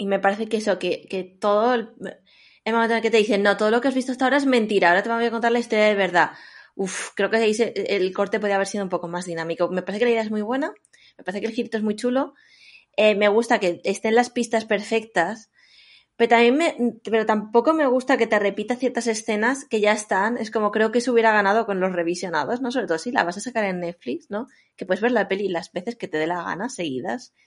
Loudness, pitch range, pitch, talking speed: -22 LUFS, 195-235 Hz, 220 Hz, 265 wpm